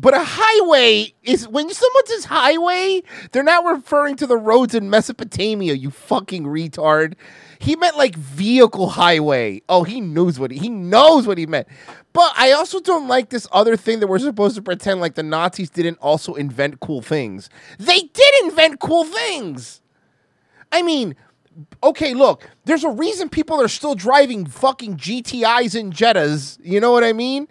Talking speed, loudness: 175 wpm, -16 LUFS